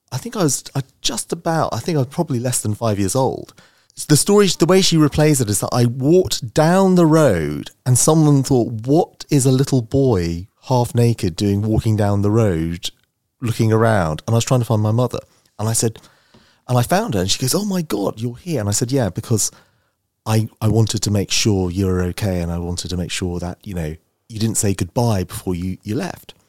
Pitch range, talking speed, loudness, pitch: 100-140 Hz, 230 wpm, -18 LUFS, 115 Hz